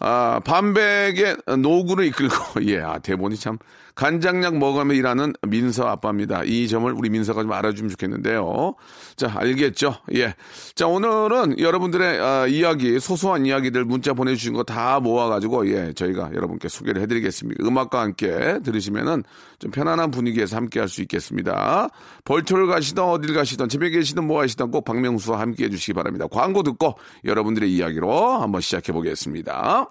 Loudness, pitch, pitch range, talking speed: -21 LUFS, 125 Hz, 110-160 Hz, 385 characters per minute